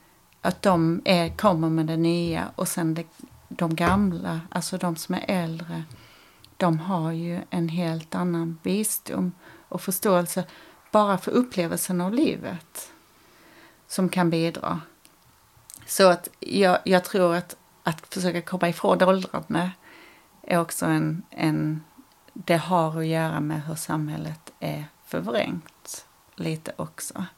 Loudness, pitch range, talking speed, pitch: -25 LUFS, 165-185 Hz, 130 wpm, 175 Hz